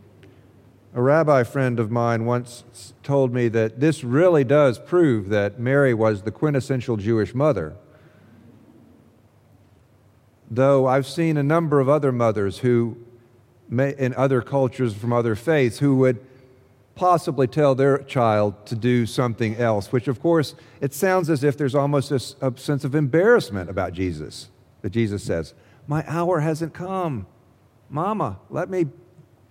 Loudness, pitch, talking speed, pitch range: -21 LUFS, 125 Hz, 140 wpm, 115-145 Hz